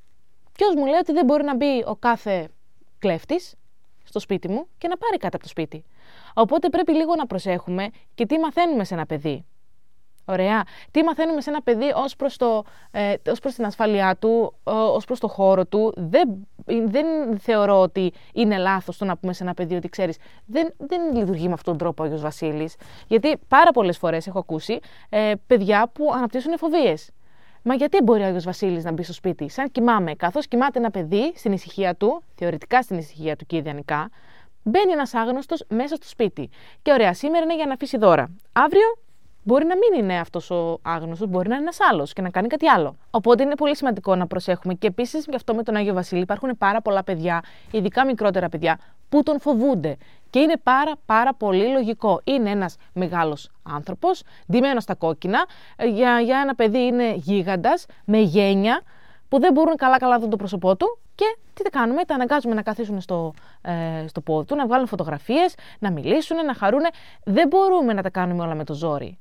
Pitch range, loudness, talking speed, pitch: 180-275 Hz, -21 LUFS, 195 wpm, 220 Hz